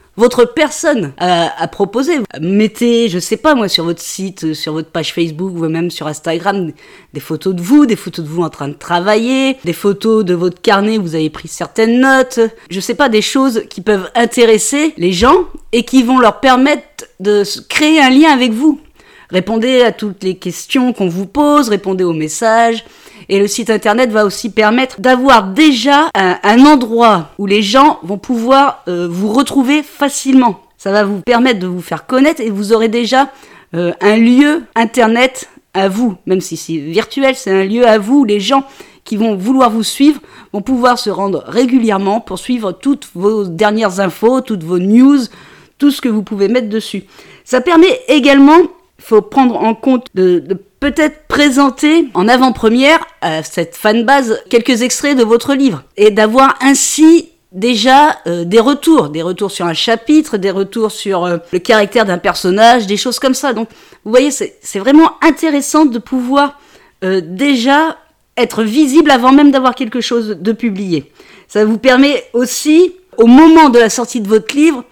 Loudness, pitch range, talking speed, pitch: -11 LUFS, 195-270 Hz, 185 wpm, 230 Hz